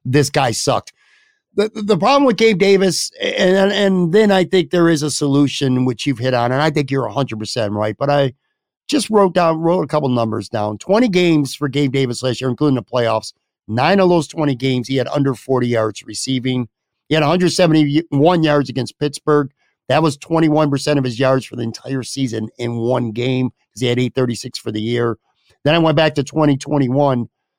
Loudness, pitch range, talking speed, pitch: -16 LUFS, 125-165 Hz, 200 wpm, 140 Hz